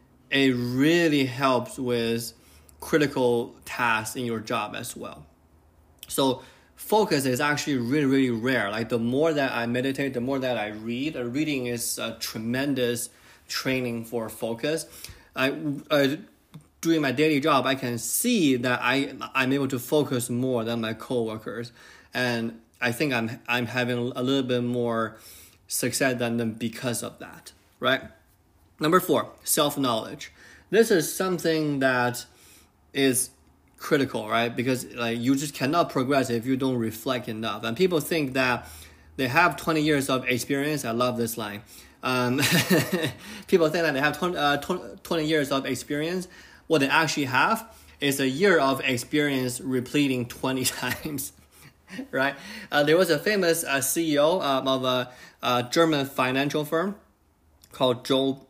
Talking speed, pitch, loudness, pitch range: 155 wpm, 130 Hz, -25 LUFS, 120-145 Hz